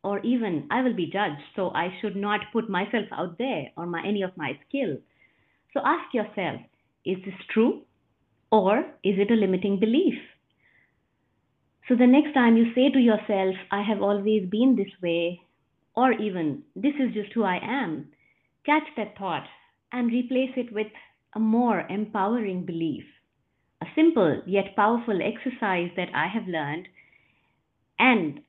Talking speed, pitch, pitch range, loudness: 160 wpm, 210 Hz, 190-245 Hz, -25 LUFS